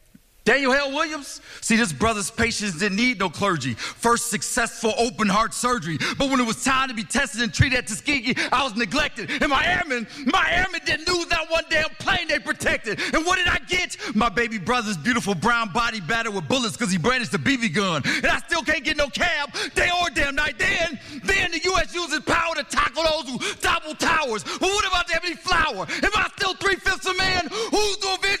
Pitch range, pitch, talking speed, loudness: 235-345 Hz, 285 Hz, 215 wpm, -22 LUFS